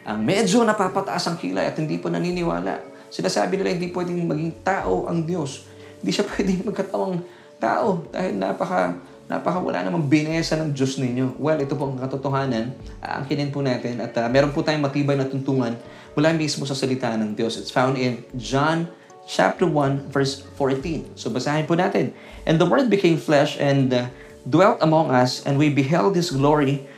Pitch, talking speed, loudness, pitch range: 140 Hz, 185 wpm, -22 LUFS, 130-165 Hz